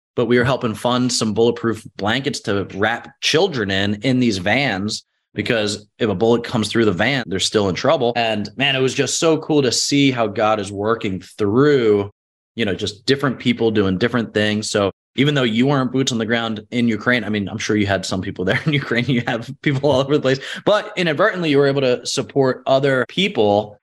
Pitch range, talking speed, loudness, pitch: 105-135 Hz, 220 wpm, -18 LUFS, 120 Hz